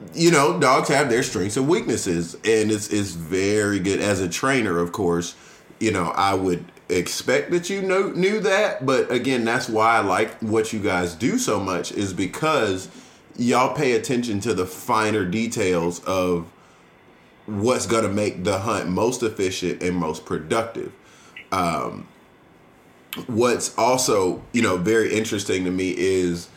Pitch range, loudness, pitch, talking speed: 90-115 Hz, -22 LUFS, 105 Hz, 160 wpm